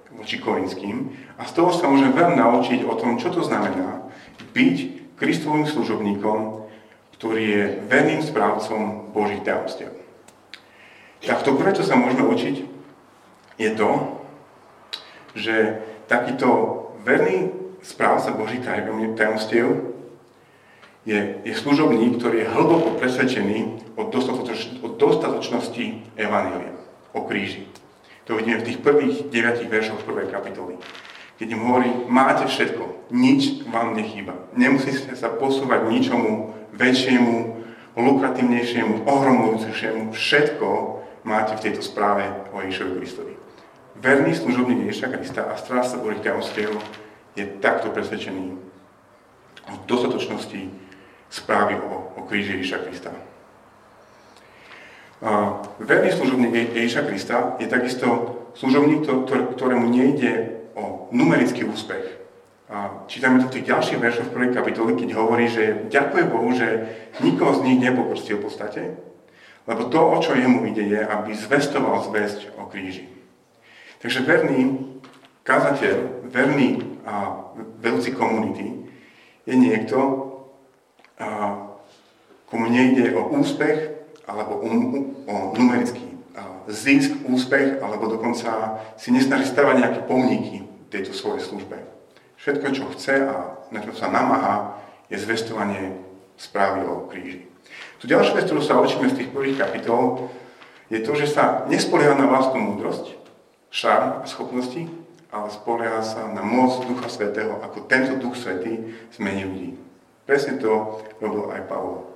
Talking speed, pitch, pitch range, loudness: 120 wpm, 115 Hz, 105-130 Hz, -21 LUFS